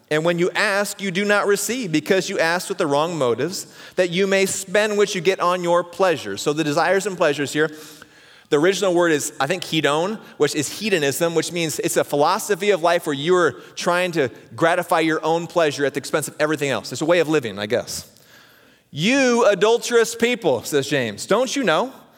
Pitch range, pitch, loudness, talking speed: 155-195 Hz, 175 Hz, -20 LUFS, 210 wpm